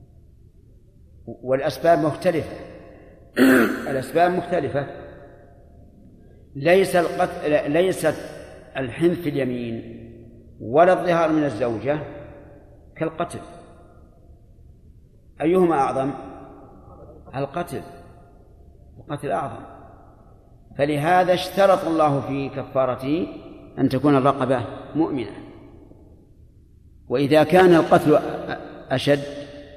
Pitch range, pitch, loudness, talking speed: 115-160 Hz, 140 Hz, -21 LUFS, 65 wpm